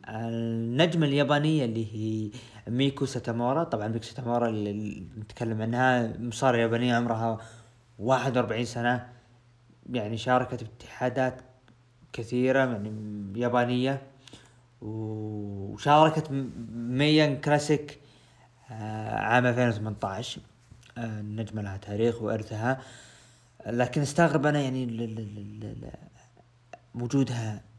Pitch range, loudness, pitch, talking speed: 110-130 Hz, -28 LUFS, 120 Hz, 80 wpm